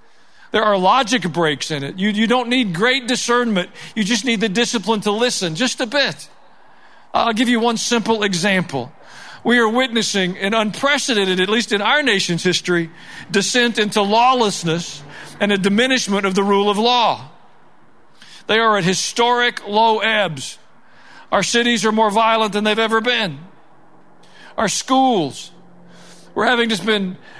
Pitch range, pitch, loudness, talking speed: 190-240 Hz, 220 Hz, -17 LUFS, 155 wpm